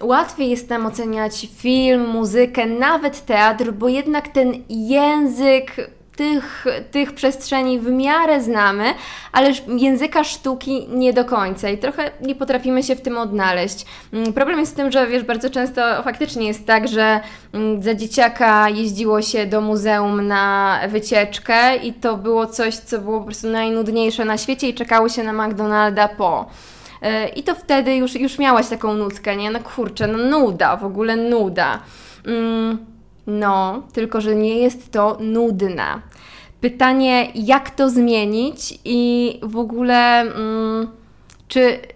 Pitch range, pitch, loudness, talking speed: 220-260 Hz, 235 Hz, -18 LUFS, 145 wpm